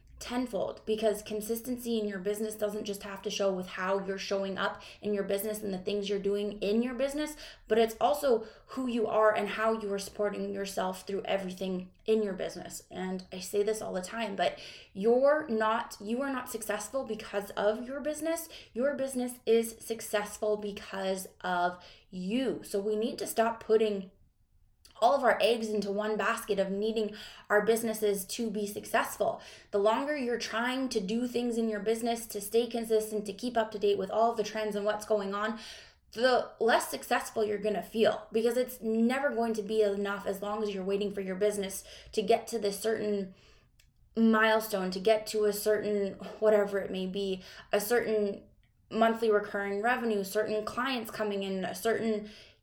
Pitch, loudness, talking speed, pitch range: 215 Hz, -31 LUFS, 185 wpm, 200-225 Hz